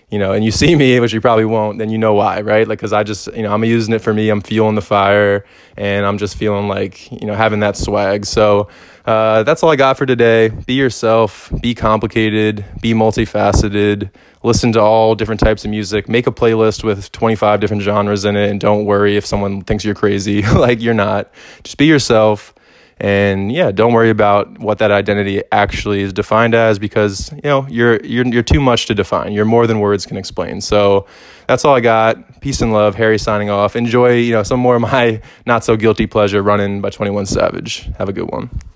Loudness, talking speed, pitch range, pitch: -14 LUFS, 220 wpm, 105-115 Hz, 110 Hz